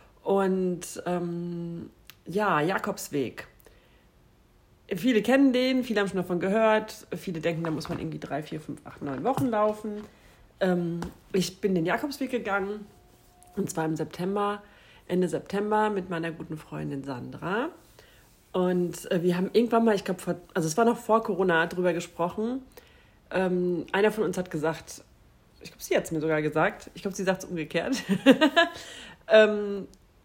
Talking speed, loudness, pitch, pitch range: 155 wpm, -27 LUFS, 185 Hz, 170-210 Hz